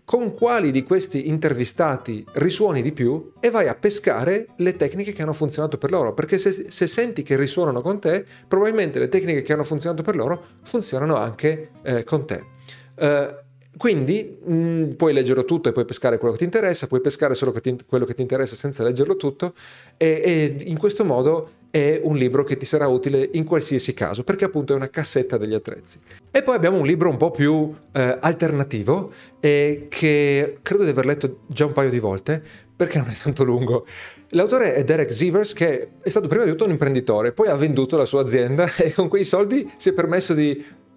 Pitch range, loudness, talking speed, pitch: 135-175 Hz, -21 LUFS, 200 wpm, 150 Hz